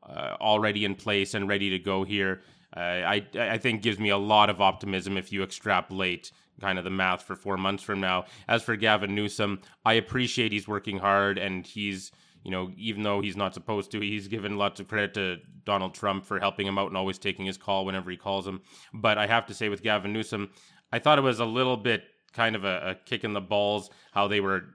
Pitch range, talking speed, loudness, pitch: 95-105 Hz, 235 wpm, -28 LUFS, 100 Hz